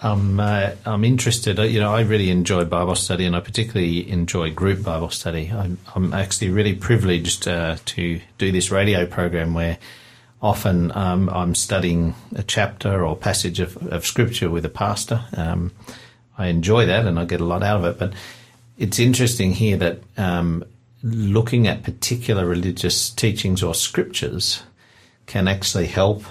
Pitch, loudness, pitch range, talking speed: 95 Hz, -21 LUFS, 90-110 Hz, 165 wpm